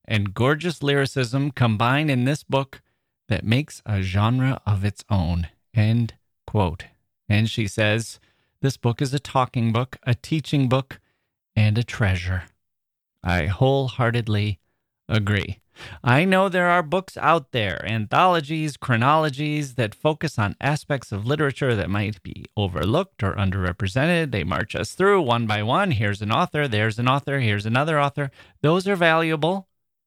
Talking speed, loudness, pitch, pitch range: 150 wpm, -22 LUFS, 120 Hz, 105-145 Hz